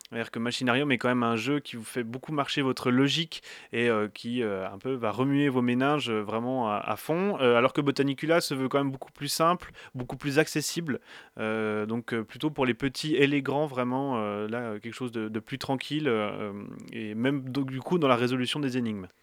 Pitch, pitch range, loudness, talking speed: 130 Hz, 115-140 Hz, -28 LUFS, 230 wpm